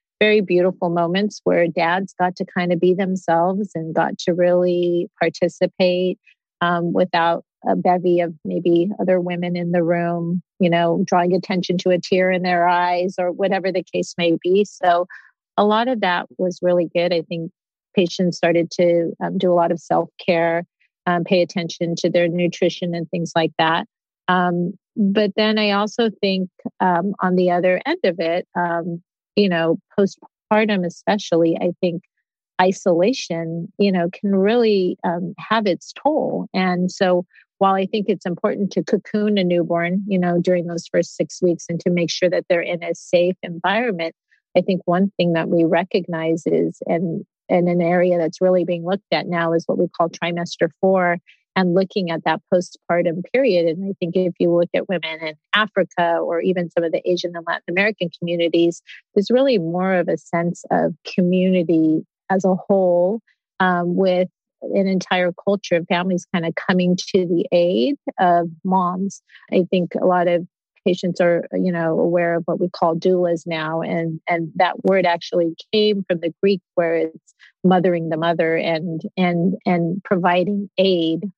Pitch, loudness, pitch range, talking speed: 180 Hz, -19 LUFS, 170-190 Hz, 175 wpm